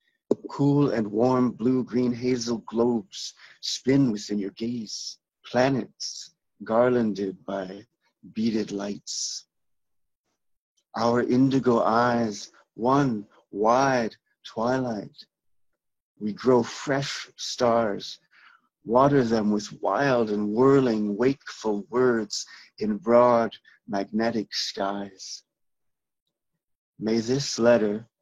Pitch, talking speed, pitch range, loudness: 115 Hz, 85 wpm, 105-125 Hz, -25 LUFS